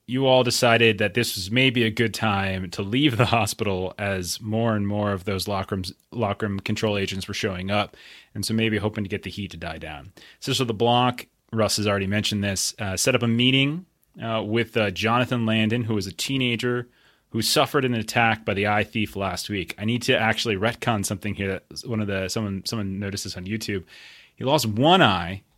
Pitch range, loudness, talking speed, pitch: 100-120 Hz, -23 LUFS, 225 wpm, 110 Hz